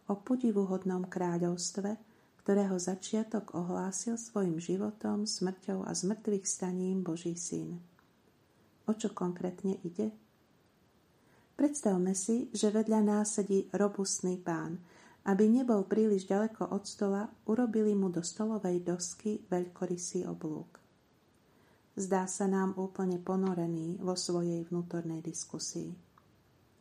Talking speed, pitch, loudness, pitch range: 105 wpm, 190 Hz, -34 LUFS, 180-210 Hz